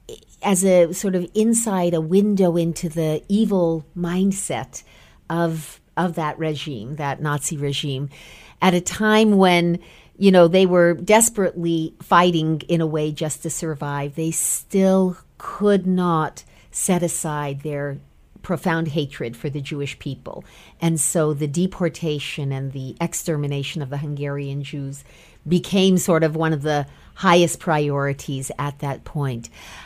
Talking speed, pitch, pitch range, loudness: 140 wpm, 160 Hz, 145-180 Hz, -20 LUFS